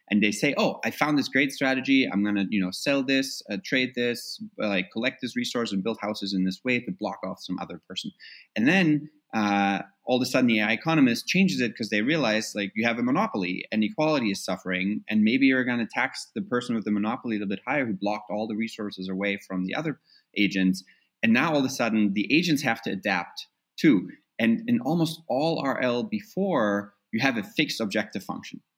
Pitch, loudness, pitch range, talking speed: 115 Hz, -26 LUFS, 100-135 Hz, 225 wpm